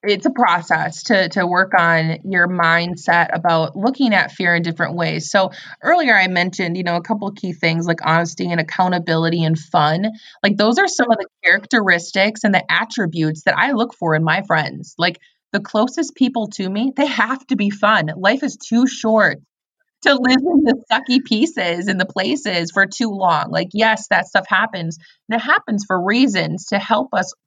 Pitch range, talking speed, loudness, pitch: 175-230 Hz, 195 wpm, -17 LUFS, 195 Hz